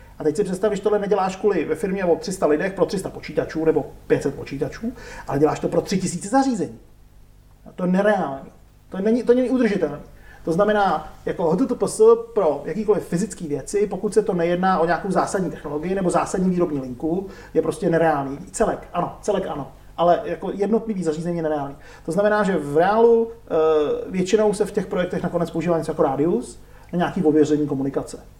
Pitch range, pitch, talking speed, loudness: 155-210 Hz, 175 Hz, 185 wpm, -21 LUFS